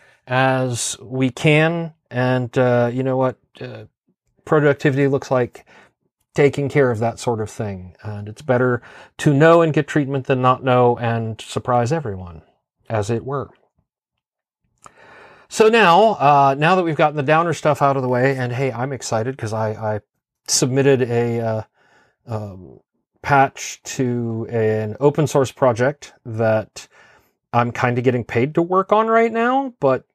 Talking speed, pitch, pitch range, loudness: 155 wpm, 130 Hz, 115-145 Hz, -18 LUFS